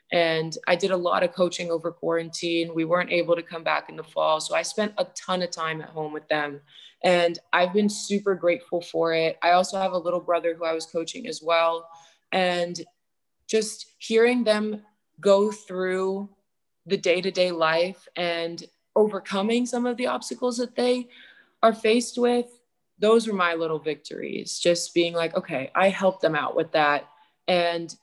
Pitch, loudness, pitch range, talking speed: 175 Hz, -25 LUFS, 165-210 Hz, 185 wpm